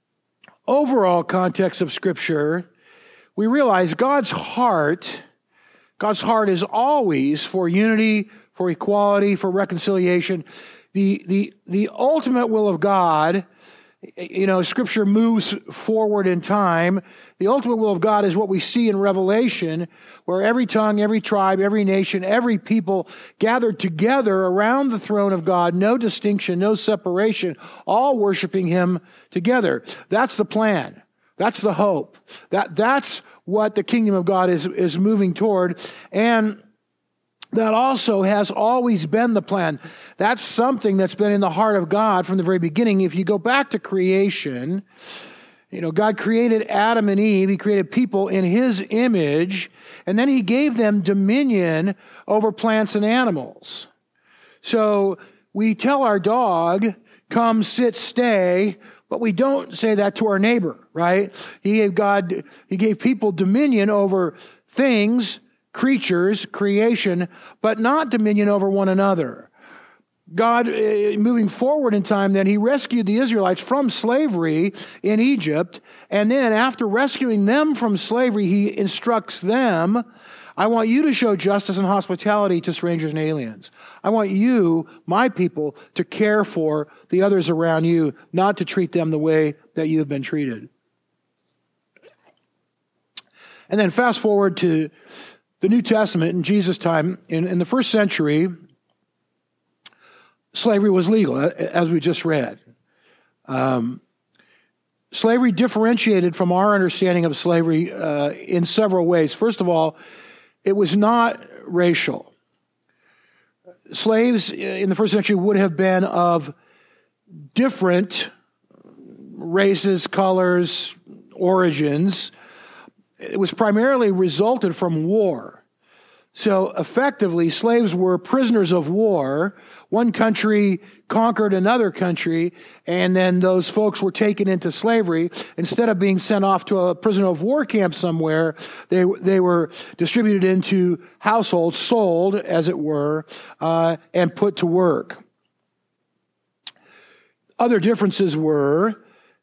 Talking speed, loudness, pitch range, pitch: 135 wpm, -19 LUFS, 180-225 Hz, 200 Hz